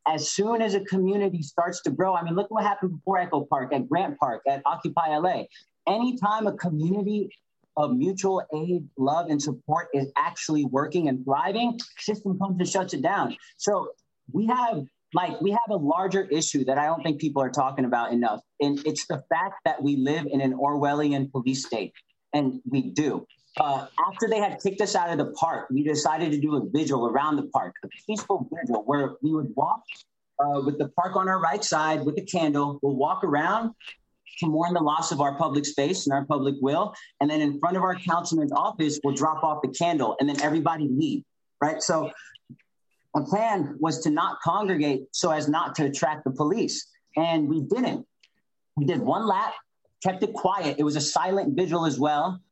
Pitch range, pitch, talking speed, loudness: 145-190 Hz, 155 Hz, 200 wpm, -26 LUFS